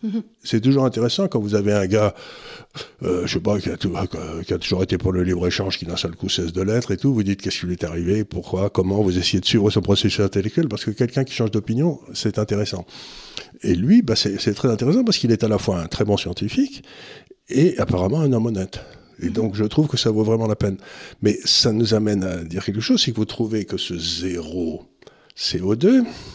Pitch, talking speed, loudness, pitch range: 105 Hz, 230 wpm, -21 LUFS, 95-115 Hz